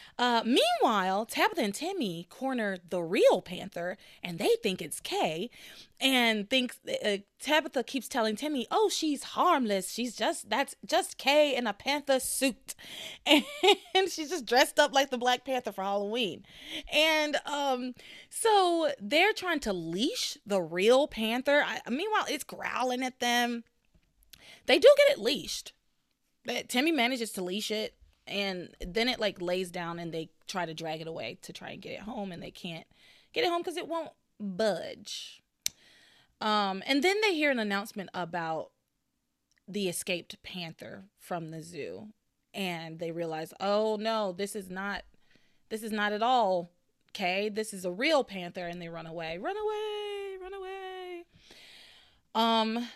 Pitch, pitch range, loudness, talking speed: 230 Hz, 190-295 Hz, -29 LUFS, 160 wpm